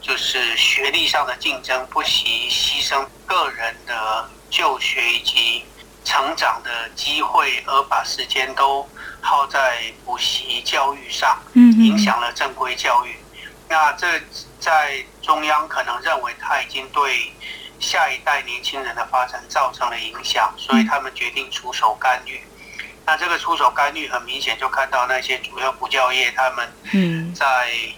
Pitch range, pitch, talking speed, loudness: 125-160 Hz, 135 Hz, 220 characters per minute, -19 LUFS